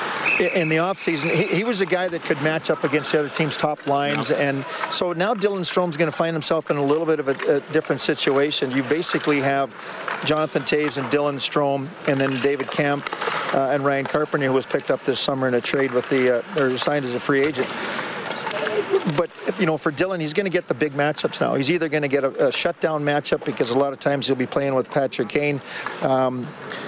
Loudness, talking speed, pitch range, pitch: -21 LUFS, 230 wpm, 140-165 Hz, 150 Hz